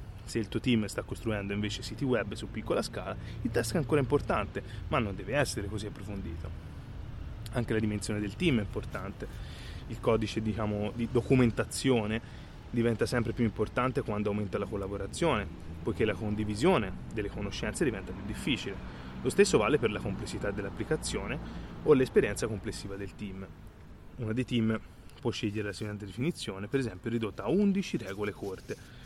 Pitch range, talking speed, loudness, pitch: 100-115 Hz, 160 wpm, -32 LUFS, 110 Hz